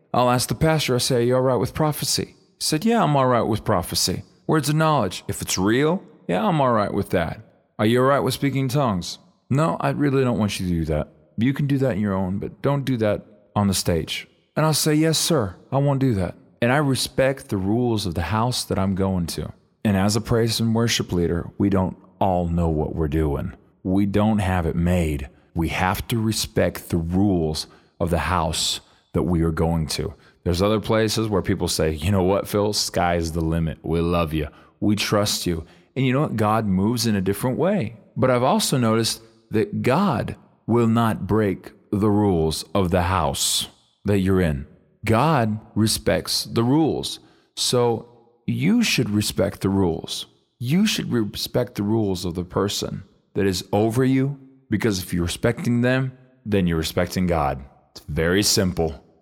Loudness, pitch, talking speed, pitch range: -22 LUFS, 105 Hz, 200 wpm, 90-125 Hz